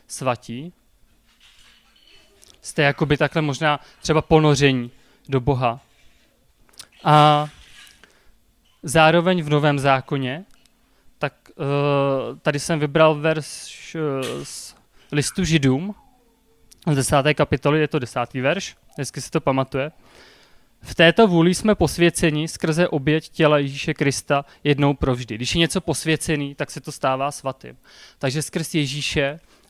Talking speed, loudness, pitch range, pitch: 115 wpm, -20 LUFS, 140-160 Hz, 150 Hz